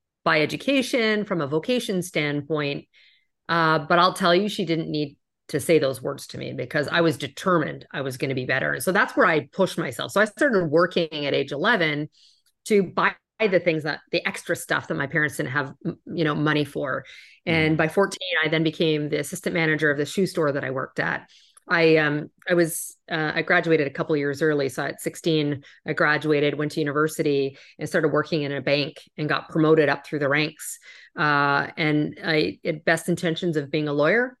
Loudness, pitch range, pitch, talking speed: -23 LUFS, 150-175 Hz, 160 Hz, 210 wpm